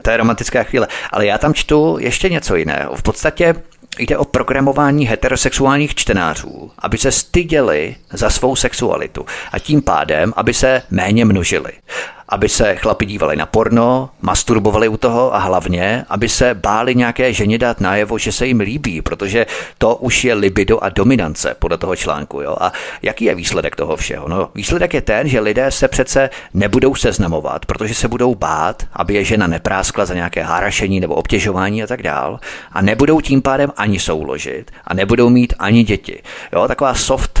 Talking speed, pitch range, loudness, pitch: 175 wpm, 100-135 Hz, -15 LUFS, 115 Hz